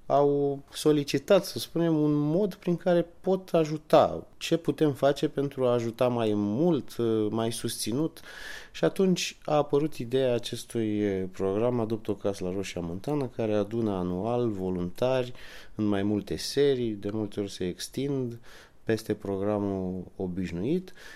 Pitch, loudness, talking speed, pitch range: 120 Hz, -28 LUFS, 140 wpm, 105-150 Hz